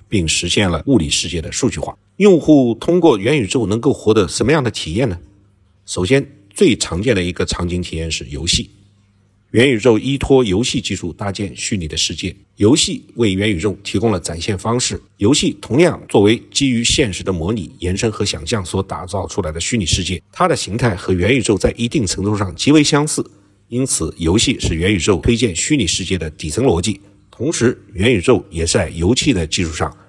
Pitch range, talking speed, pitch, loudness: 90-120 Hz, 305 characters per minute, 100 Hz, -16 LUFS